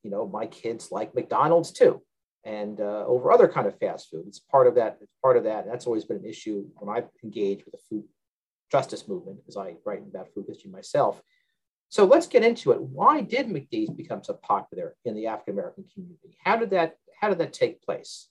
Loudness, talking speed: -25 LUFS, 215 wpm